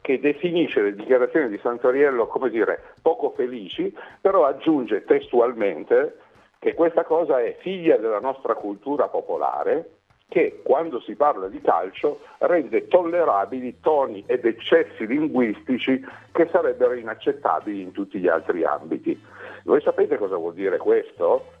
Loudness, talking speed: -22 LUFS, 135 wpm